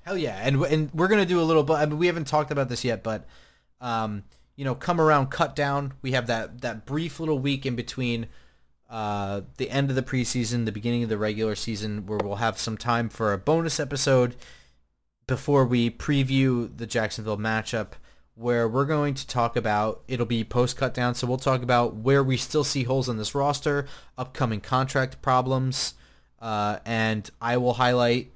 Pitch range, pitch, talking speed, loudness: 110-140 Hz, 125 Hz, 195 wpm, -25 LUFS